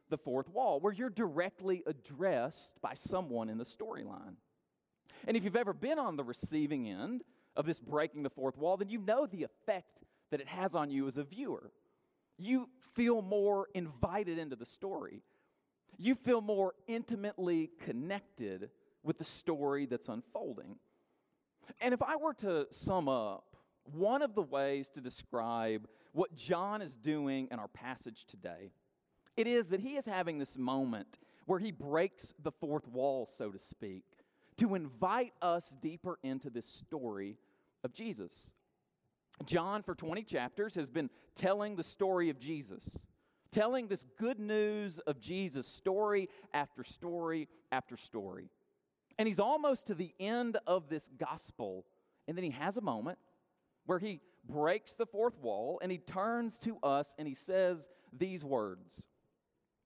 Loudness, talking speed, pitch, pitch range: -38 LUFS, 155 wpm, 180 Hz, 140-220 Hz